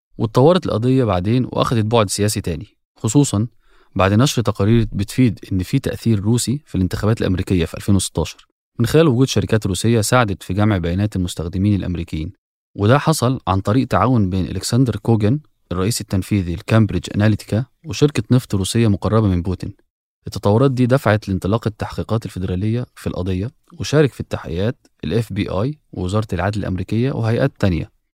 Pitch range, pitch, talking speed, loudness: 95-120 Hz, 105 Hz, 145 wpm, -18 LUFS